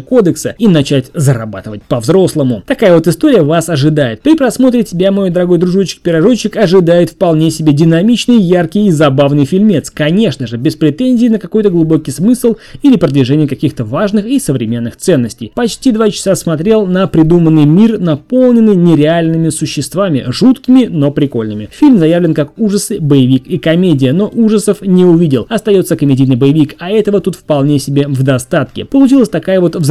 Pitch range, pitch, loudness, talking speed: 145-210 Hz, 170 Hz, -10 LUFS, 155 wpm